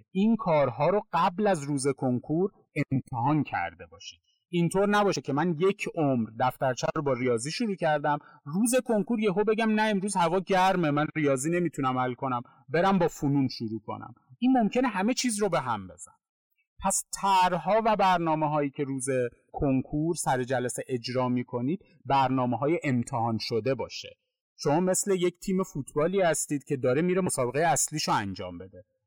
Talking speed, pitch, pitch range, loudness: 165 wpm, 155 Hz, 130-195 Hz, -27 LUFS